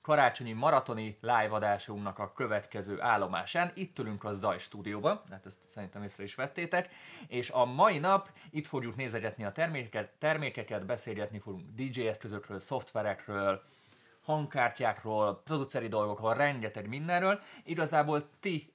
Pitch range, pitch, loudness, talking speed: 105-150 Hz, 120 Hz, -33 LUFS, 130 wpm